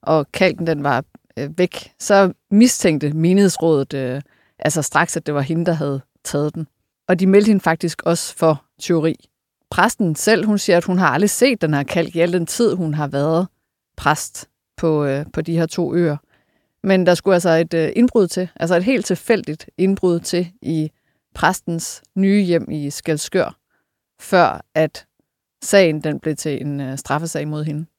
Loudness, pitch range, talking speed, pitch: -18 LUFS, 150-185 Hz, 180 wpm, 165 Hz